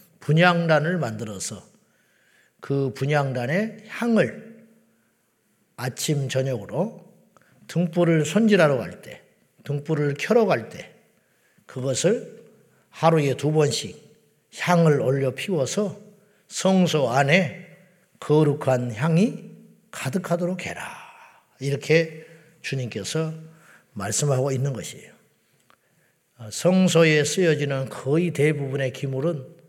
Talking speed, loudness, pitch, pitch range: 205 characters per minute, -23 LUFS, 155 Hz, 135-180 Hz